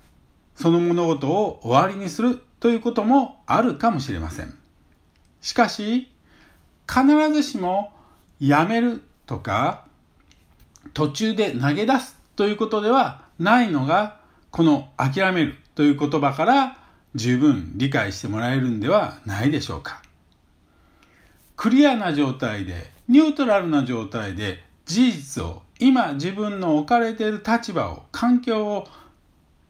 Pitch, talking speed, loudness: 175 Hz, 255 characters per minute, -21 LUFS